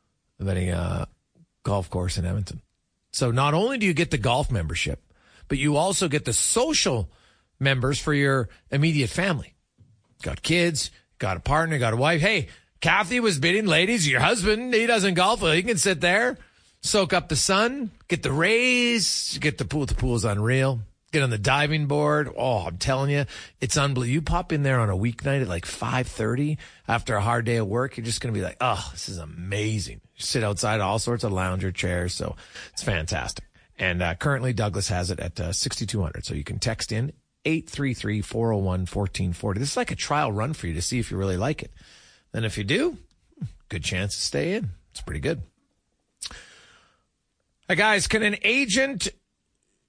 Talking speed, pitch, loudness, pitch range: 190 wpm, 125 Hz, -24 LUFS, 100-155 Hz